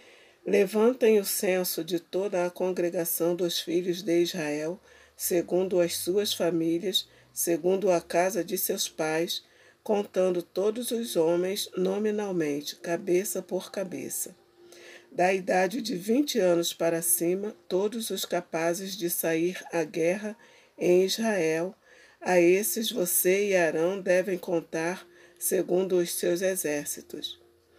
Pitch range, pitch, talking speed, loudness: 170-195 Hz, 180 Hz, 120 wpm, -27 LUFS